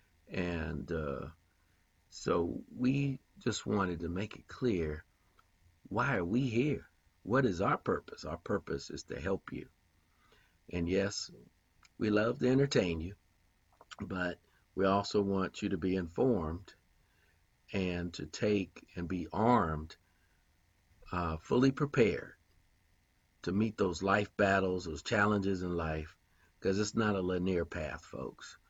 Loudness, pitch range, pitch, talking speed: -34 LUFS, 85-100 Hz, 90 Hz, 135 wpm